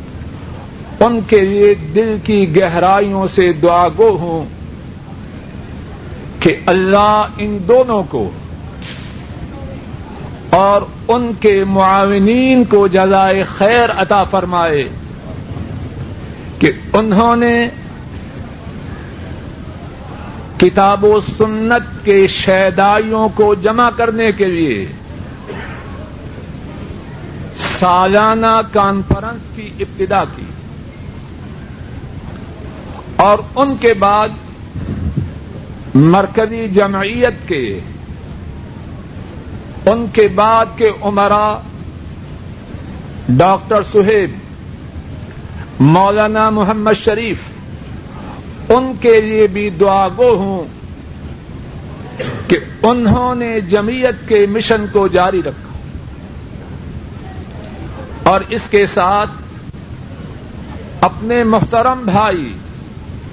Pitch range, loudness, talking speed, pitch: 190-220 Hz, -12 LUFS, 80 wpm, 205 Hz